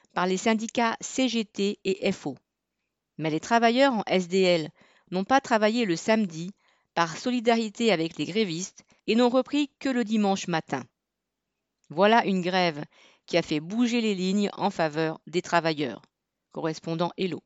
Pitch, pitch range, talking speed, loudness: 190 Hz, 165-225 Hz, 150 wpm, -26 LUFS